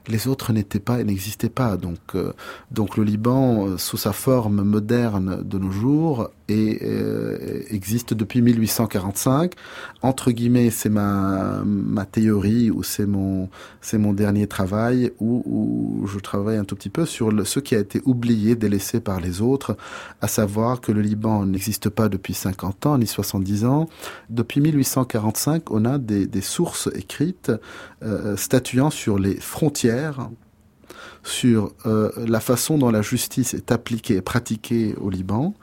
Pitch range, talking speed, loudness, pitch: 100-120 Hz, 160 wpm, -22 LUFS, 110 Hz